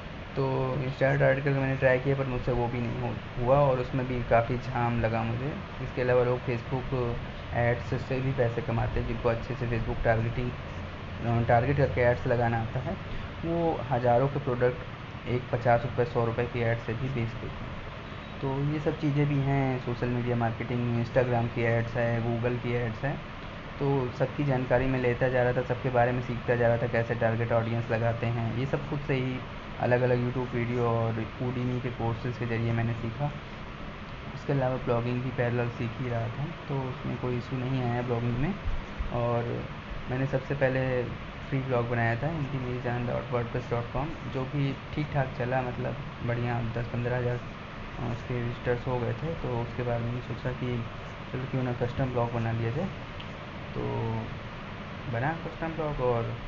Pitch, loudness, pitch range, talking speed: 120 Hz, -30 LUFS, 115-130 Hz, 185 wpm